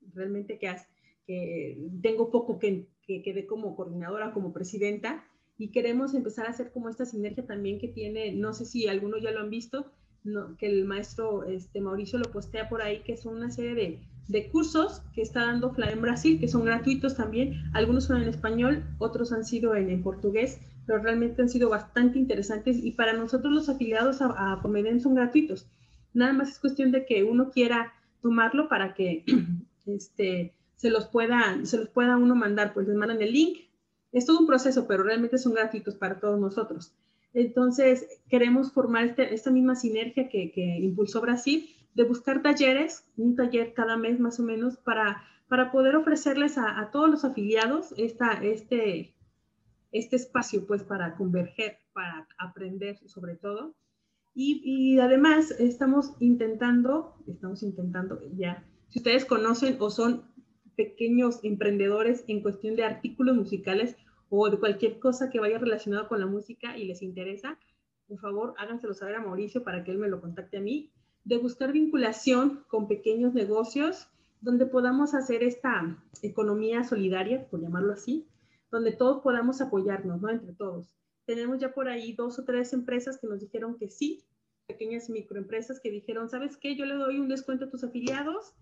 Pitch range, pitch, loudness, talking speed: 205-255 Hz, 230 Hz, -28 LUFS, 175 wpm